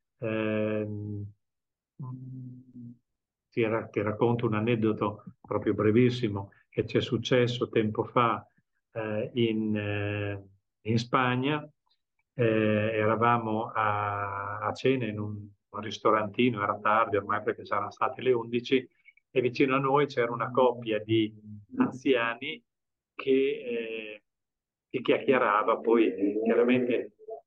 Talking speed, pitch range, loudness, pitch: 115 wpm, 105-125 Hz, -28 LUFS, 115 Hz